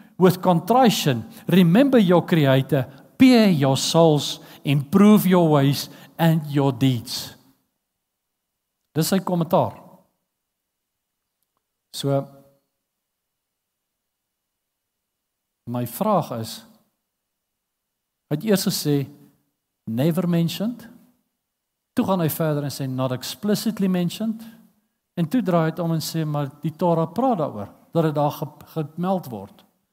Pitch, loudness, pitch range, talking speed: 165 Hz, -21 LUFS, 140-195 Hz, 105 wpm